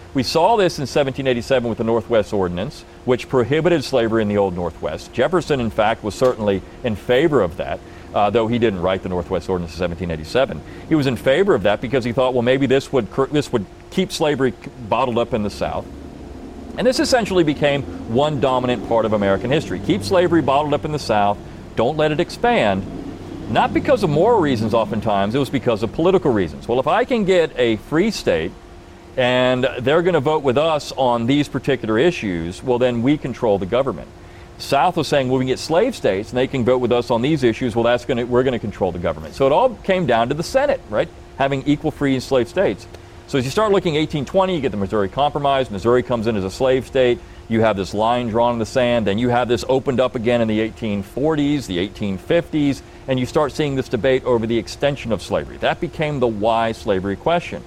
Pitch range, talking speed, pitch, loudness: 110-145 Hz, 220 wpm, 125 Hz, -19 LUFS